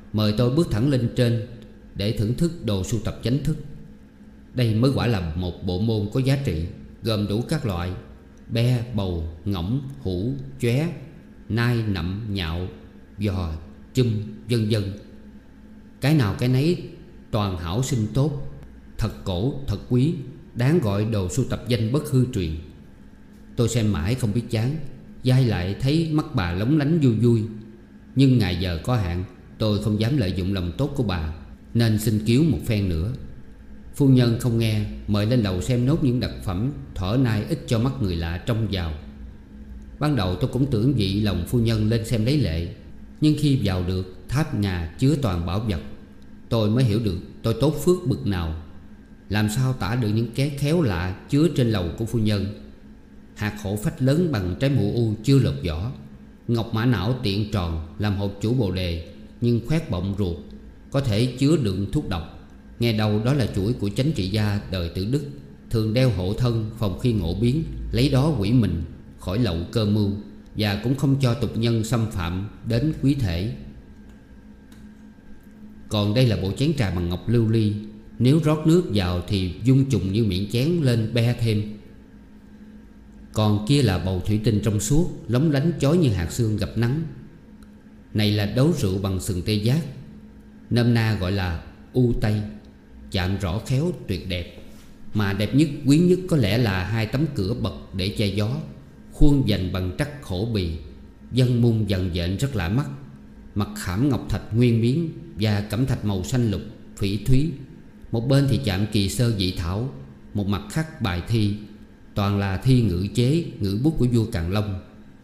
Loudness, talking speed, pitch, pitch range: -23 LUFS, 185 wpm, 110 Hz, 95-130 Hz